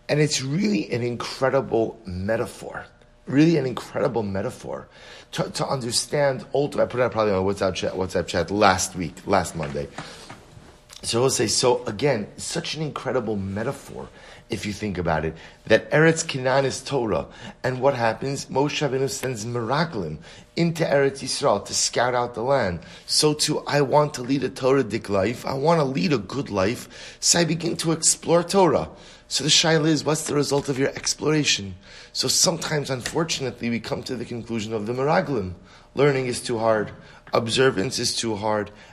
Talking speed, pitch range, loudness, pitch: 175 wpm, 110-150 Hz, -23 LUFS, 130 Hz